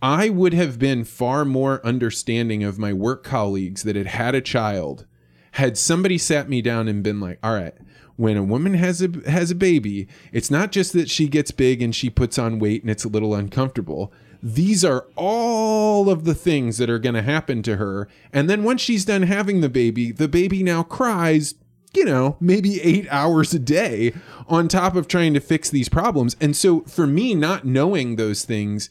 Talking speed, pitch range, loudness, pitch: 205 wpm, 115-175 Hz, -20 LUFS, 135 Hz